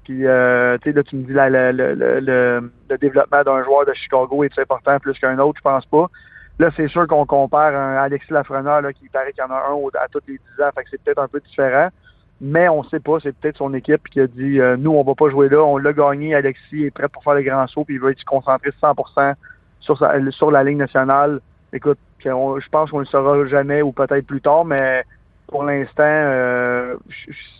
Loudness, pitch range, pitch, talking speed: -17 LUFS, 135-145 Hz, 140 Hz, 240 wpm